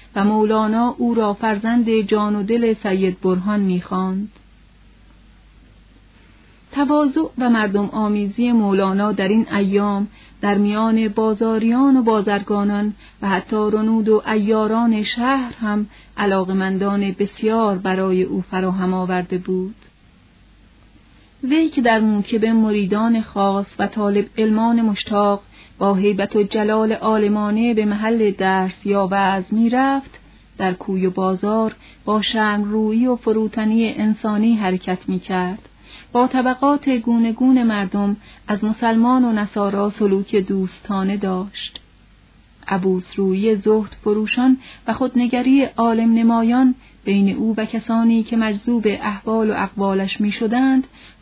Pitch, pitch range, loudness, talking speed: 210 Hz, 195-225 Hz, -18 LUFS, 120 wpm